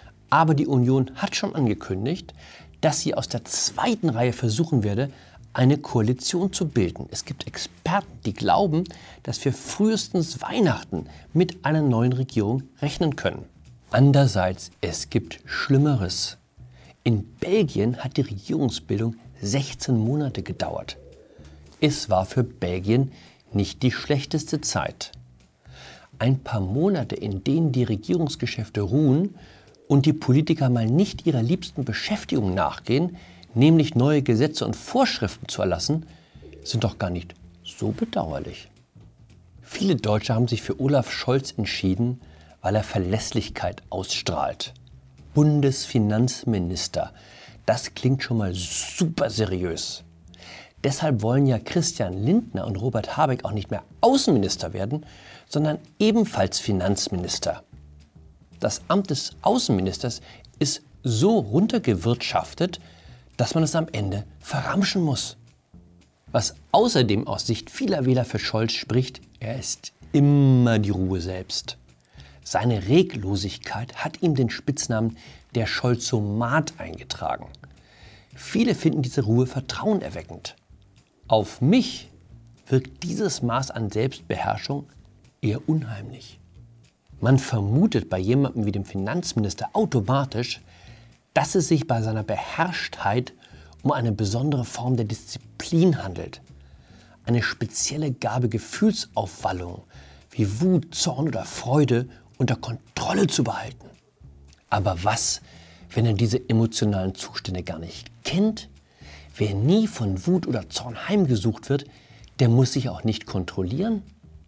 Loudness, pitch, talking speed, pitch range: -24 LUFS, 120 Hz, 120 wpm, 100-145 Hz